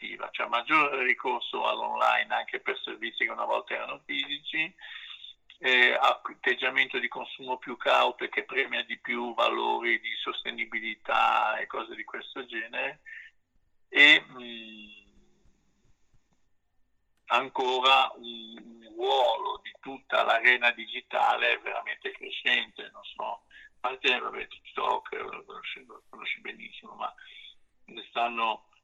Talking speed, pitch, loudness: 120 wpm, 135 Hz, -27 LUFS